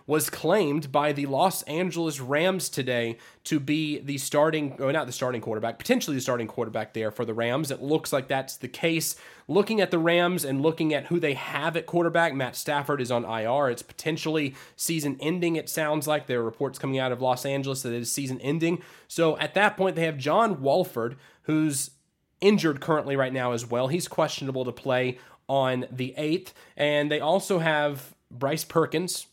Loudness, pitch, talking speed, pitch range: -26 LUFS, 145 Hz, 195 wpm, 130-160 Hz